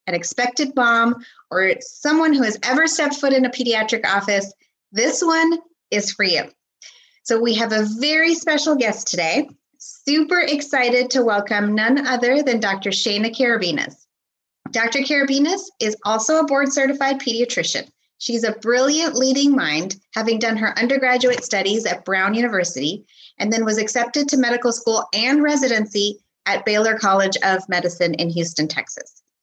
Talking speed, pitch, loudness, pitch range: 150 wpm, 235 Hz, -19 LUFS, 205-280 Hz